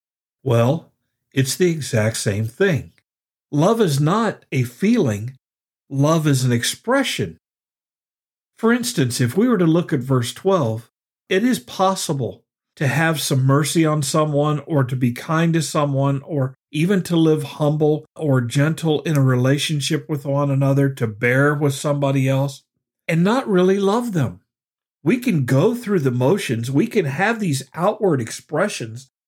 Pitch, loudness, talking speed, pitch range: 145 Hz, -19 LUFS, 155 wpm, 130-165 Hz